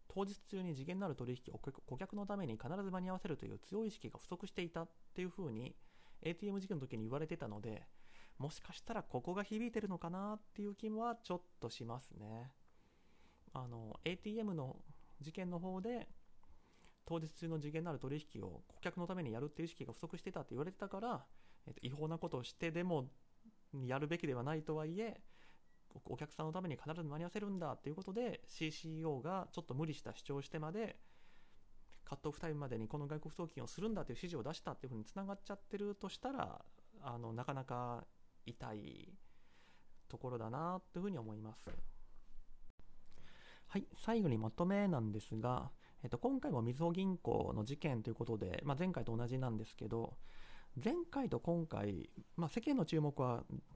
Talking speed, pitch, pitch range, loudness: 380 characters per minute, 155 Hz, 120-185 Hz, -44 LUFS